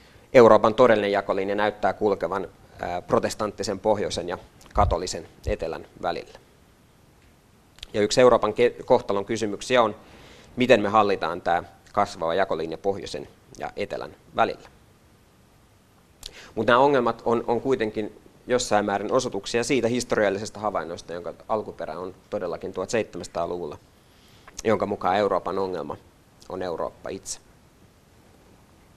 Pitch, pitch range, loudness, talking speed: 110 Hz, 100-120 Hz, -24 LUFS, 105 wpm